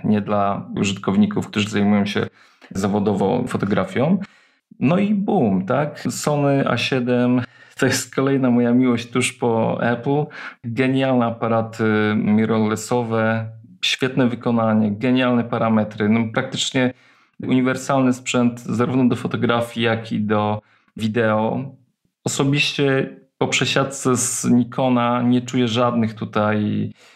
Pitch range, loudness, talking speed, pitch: 110-130 Hz, -20 LUFS, 110 wpm, 120 Hz